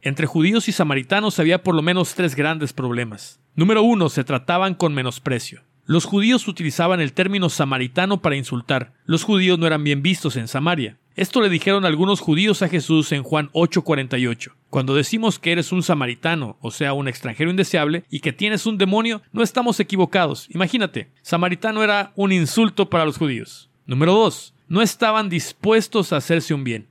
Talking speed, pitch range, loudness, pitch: 175 wpm, 140-195 Hz, -19 LUFS, 170 Hz